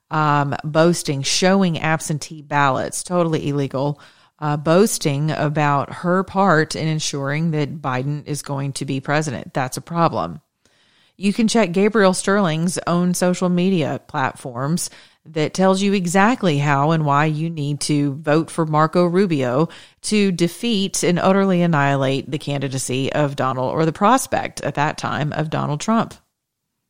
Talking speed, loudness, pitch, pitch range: 145 wpm, -19 LUFS, 155 Hz, 145-180 Hz